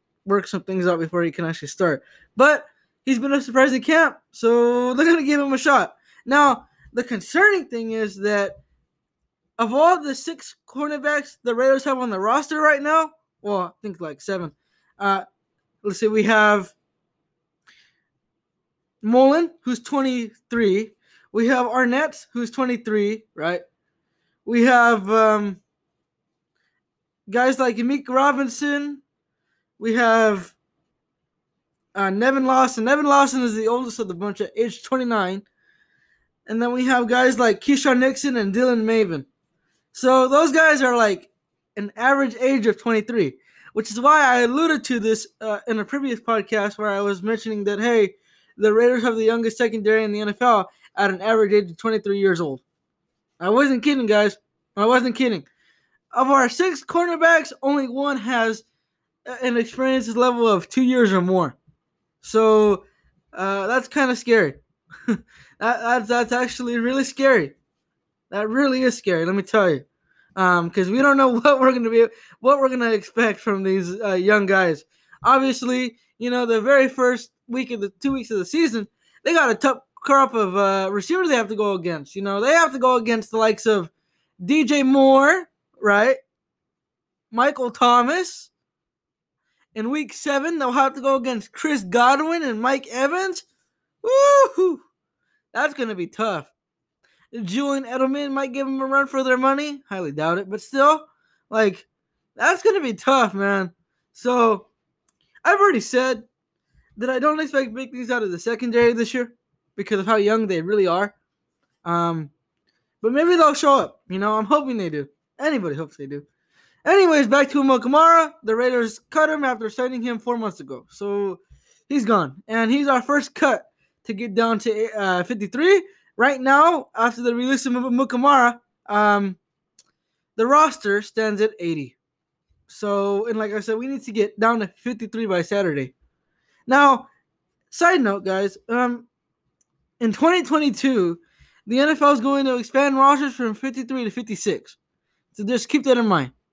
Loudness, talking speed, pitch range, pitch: -20 LUFS, 165 wpm, 210-270 Hz, 240 Hz